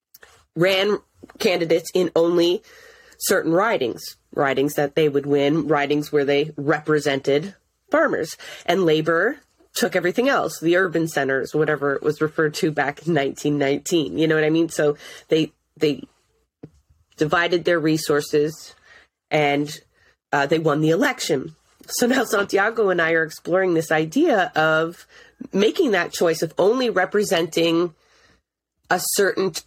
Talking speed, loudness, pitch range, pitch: 140 wpm, -21 LUFS, 150-180 Hz, 160 Hz